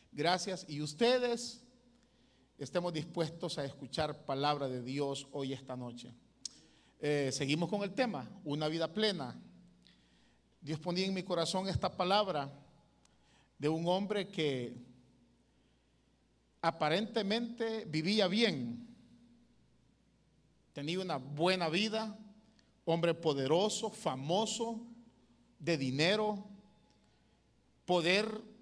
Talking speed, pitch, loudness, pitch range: 95 wpm, 170 Hz, -35 LUFS, 145-215 Hz